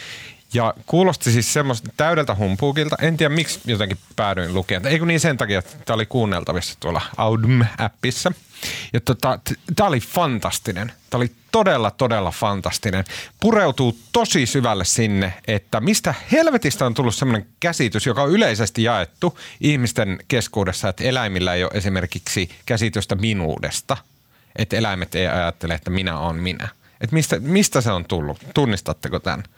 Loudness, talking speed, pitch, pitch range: -20 LUFS, 145 wpm, 115 Hz, 95-140 Hz